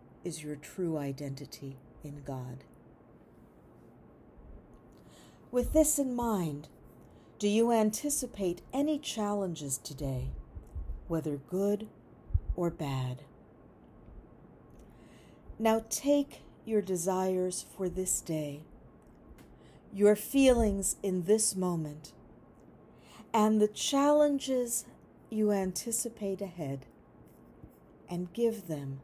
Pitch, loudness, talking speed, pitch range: 185 Hz, -31 LUFS, 85 wpm, 140-220 Hz